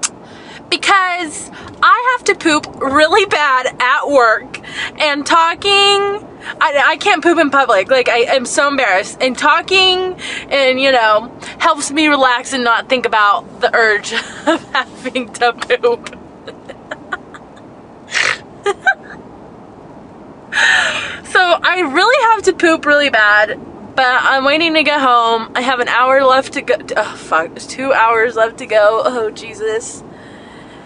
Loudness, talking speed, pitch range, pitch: -13 LUFS, 140 wpm, 240-350 Hz, 285 Hz